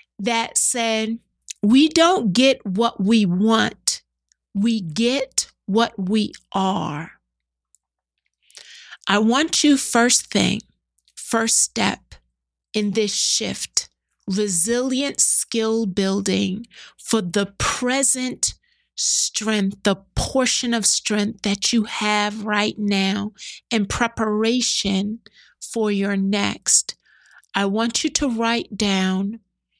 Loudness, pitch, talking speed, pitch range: -20 LUFS, 215 Hz, 100 wpm, 195-235 Hz